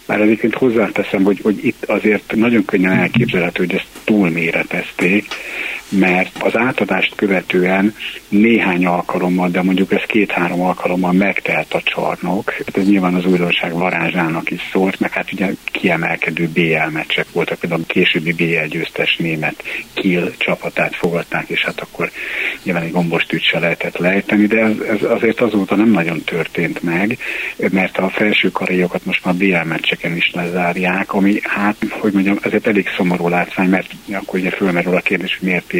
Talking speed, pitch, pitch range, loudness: 155 wpm, 95 Hz, 90-100 Hz, -16 LUFS